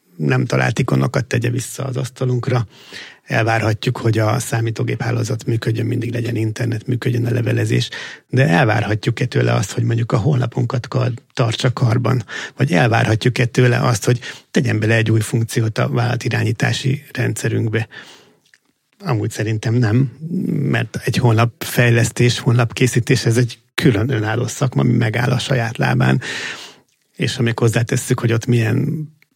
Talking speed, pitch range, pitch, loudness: 135 wpm, 115-130 Hz, 120 Hz, -18 LUFS